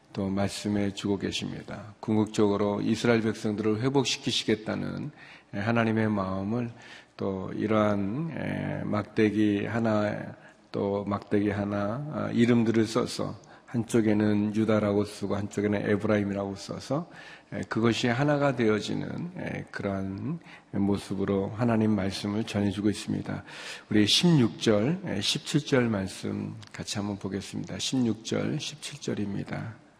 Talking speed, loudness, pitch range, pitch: 265 characters per minute, -28 LUFS, 100-115 Hz, 105 Hz